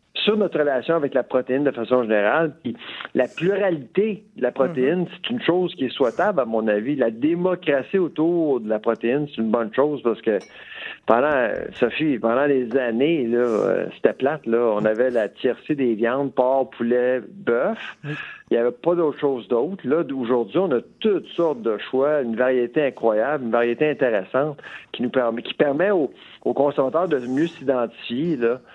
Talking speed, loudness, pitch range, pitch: 175 wpm, -22 LUFS, 120-160 Hz, 135 Hz